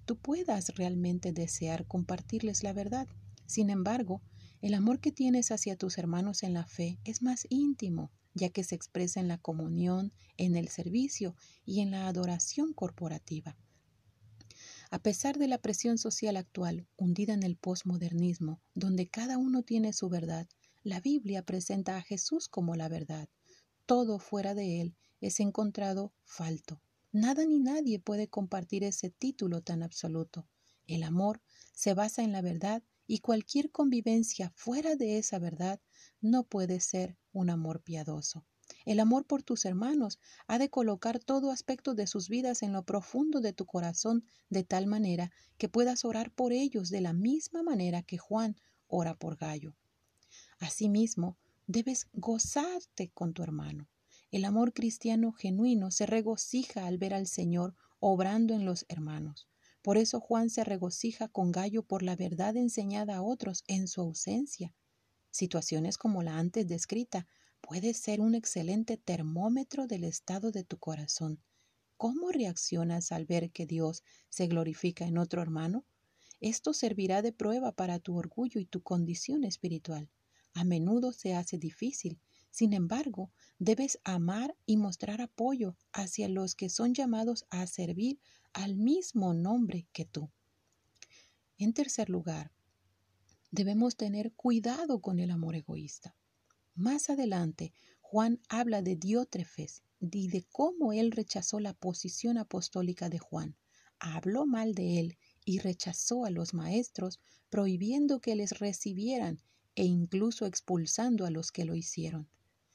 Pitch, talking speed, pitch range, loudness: 195 Hz, 145 wpm, 170-225 Hz, -34 LUFS